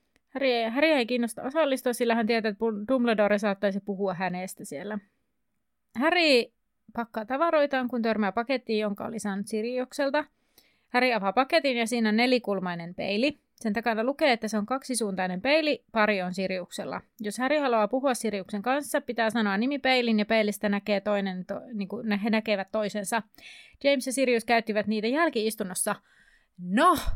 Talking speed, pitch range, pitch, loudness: 150 wpm, 210-260 Hz, 230 Hz, -27 LUFS